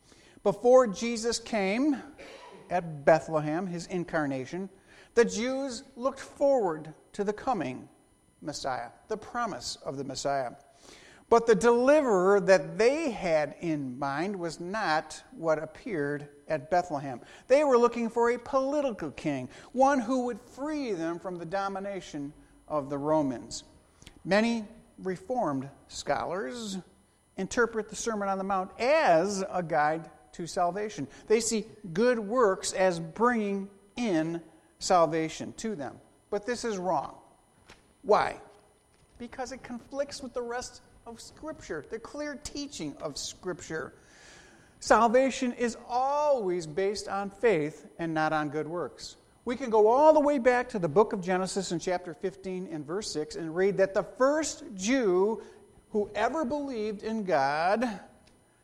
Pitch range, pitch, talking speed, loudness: 170-240 Hz, 200 Hz, 135 wpm, -29 LUFS